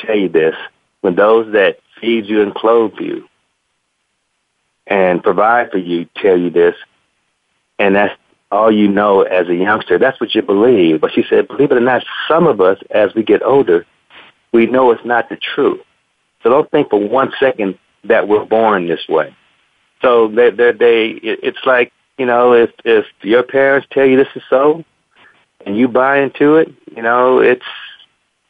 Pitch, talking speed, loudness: 130 Hz, 180 wpm, -13 LUFS